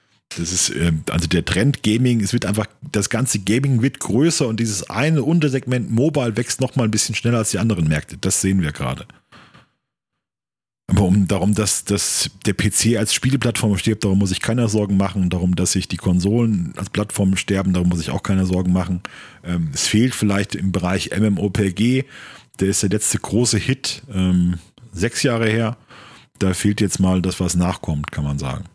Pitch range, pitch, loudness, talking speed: 95-115 Hz, 105 Hz, -19 LUFS, 185 wpm